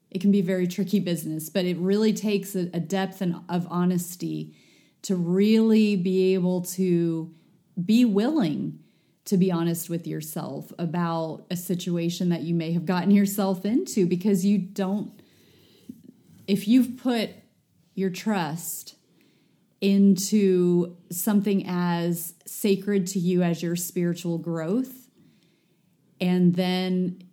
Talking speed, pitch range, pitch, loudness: 125 wpm, 175-200 Hz, 180 Hz, -25 LUFS